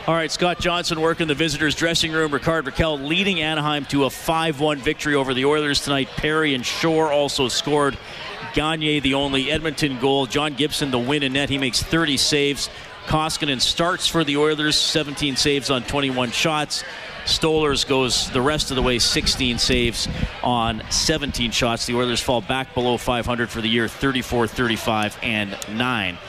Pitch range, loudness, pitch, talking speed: 125-155 Hz, -20 LUFS, 140 Hz, 175 wpm